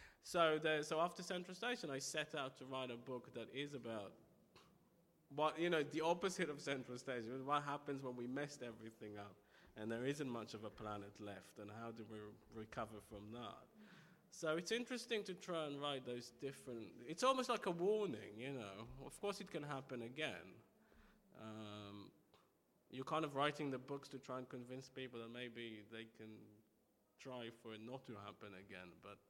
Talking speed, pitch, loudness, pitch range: 185 wpm, 130 Hz, -46 LUFS, 110-155 Hz